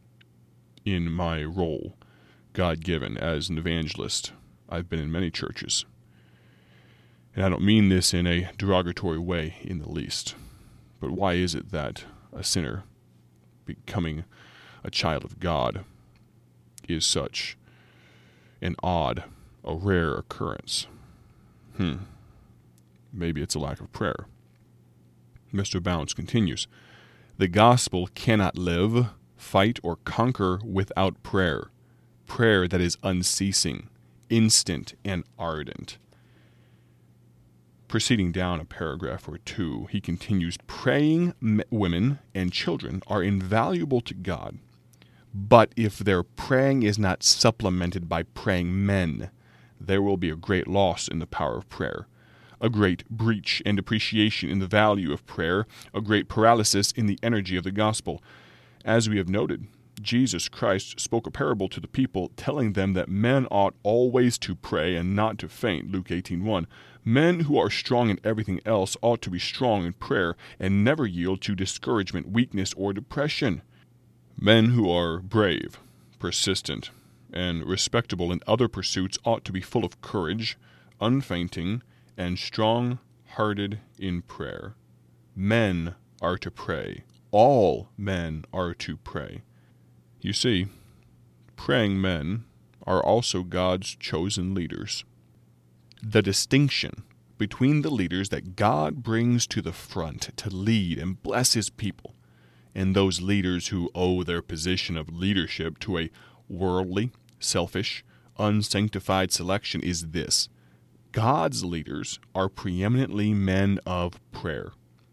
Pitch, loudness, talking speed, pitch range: 95 Hz, -26 LUFS, 135 wpm, 85-110 Hz